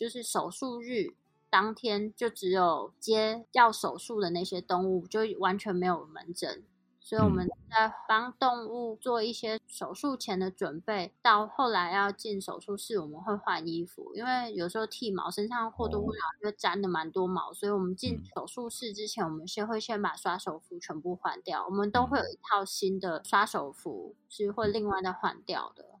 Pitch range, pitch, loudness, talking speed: 185-225 Hz, 205 Hz, -31 LUFS, 275 characters per minute